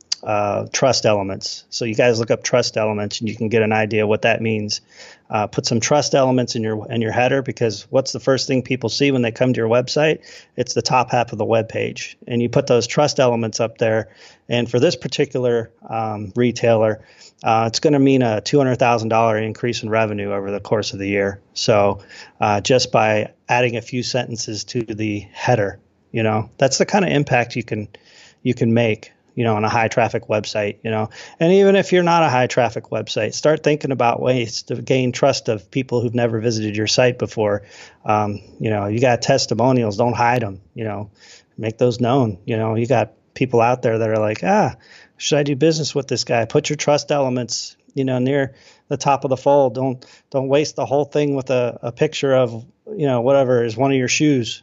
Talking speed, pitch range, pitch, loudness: 220 wpm, 110-135 Hz, 120 Hz, -19 LUFS